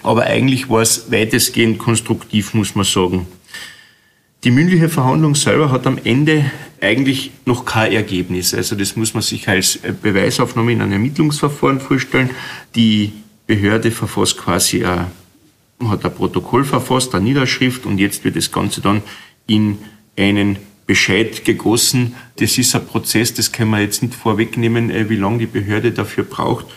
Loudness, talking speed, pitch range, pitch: -15 LUFS, 150 wpm, 100-125 Hz, 115 Hz